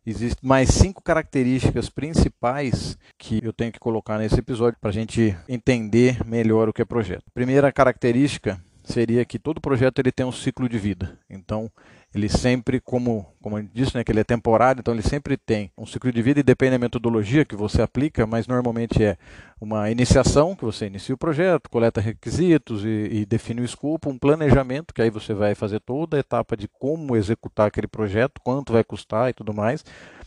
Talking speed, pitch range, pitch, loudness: 195 wpm, 110-130 Hz, 115 Hz, -22 LUFS